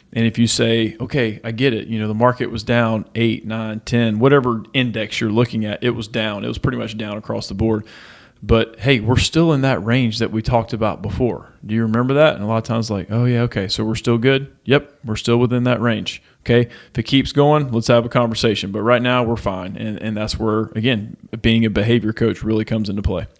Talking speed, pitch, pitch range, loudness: 245 wpm, 115 Hz, 110-125 Hz, -18 LUFS